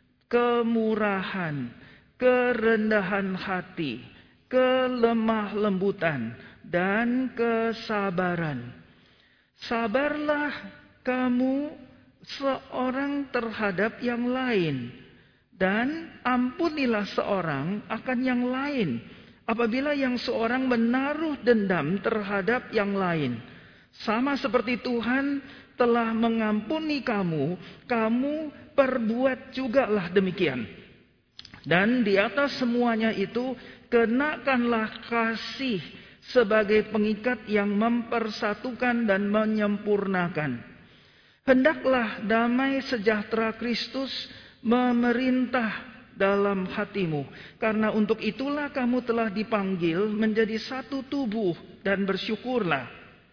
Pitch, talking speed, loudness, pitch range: 230 Hz, 75 wpm, -26 LUFS, 205-255 Hz